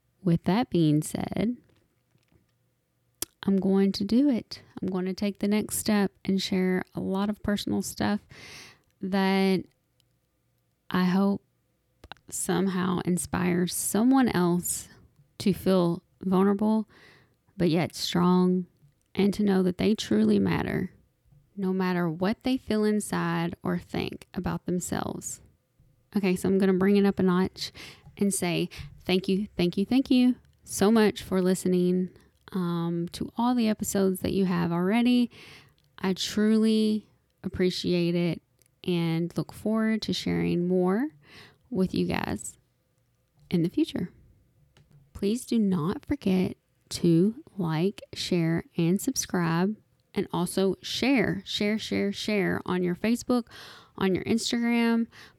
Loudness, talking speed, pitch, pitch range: -27 LUFS, 130 wpm, 190 Hz, 175-210 Hz